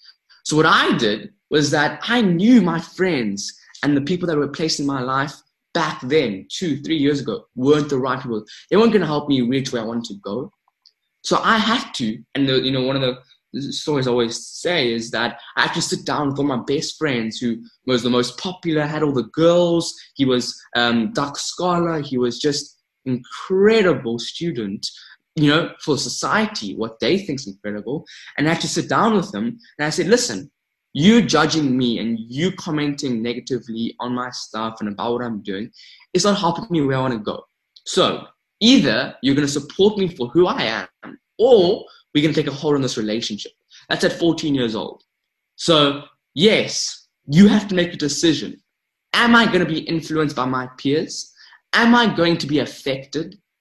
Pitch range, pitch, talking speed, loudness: 125-170 Hz, 145 Hz, 200 wpm, -19 LUFS